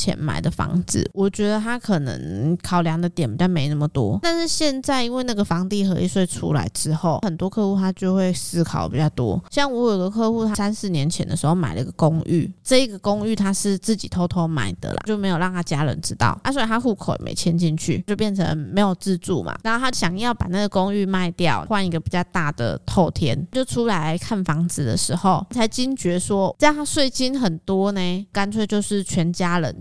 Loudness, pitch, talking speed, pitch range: -21 LUFS, 185 Hz, 320 characters per minute, 170-215 Hz